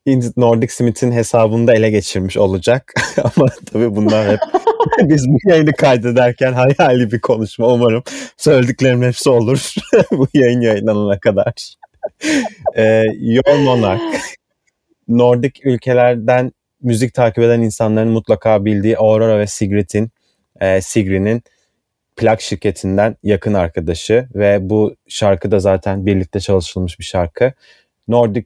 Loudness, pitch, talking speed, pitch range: -14 LUFS, 115 Hz, 120 wpm, 105-125 Hz